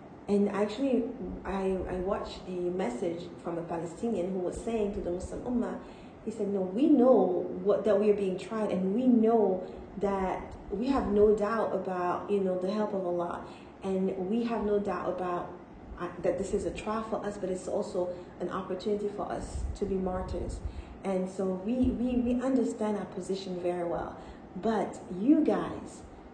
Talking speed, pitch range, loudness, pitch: 180 wpm, 185-215 Hz, -31 LUFS, 195 Hz